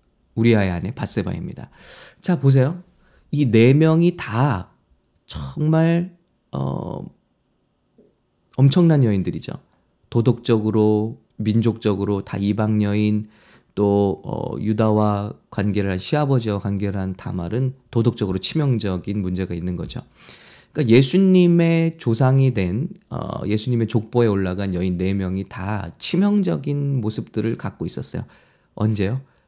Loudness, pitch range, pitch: -20 LUFS, 100-135 Hz, 110 Hz